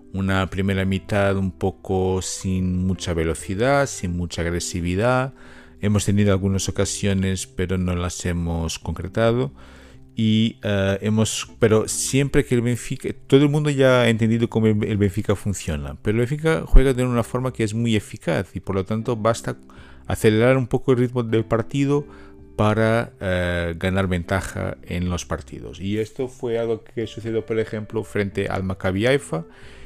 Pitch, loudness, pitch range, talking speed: 100 Hz, -22 LUFS, 95-115 Hz, 160 wpm